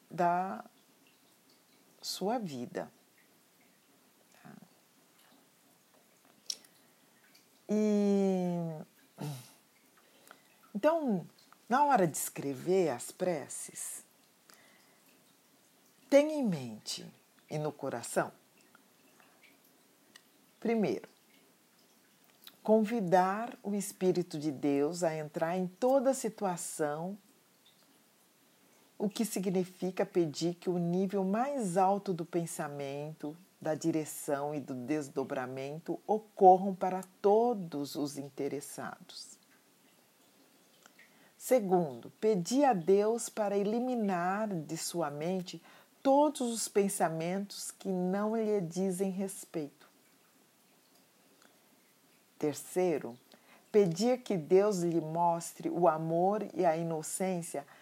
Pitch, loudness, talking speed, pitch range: 185 Hz, -33 LUFS, 80 wpm, 160-205 Hz